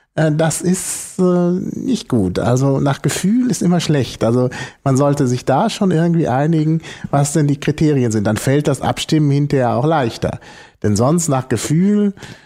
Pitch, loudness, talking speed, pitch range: 145 Hz, -16 LUFS, 170 wpm, 130-170 Hz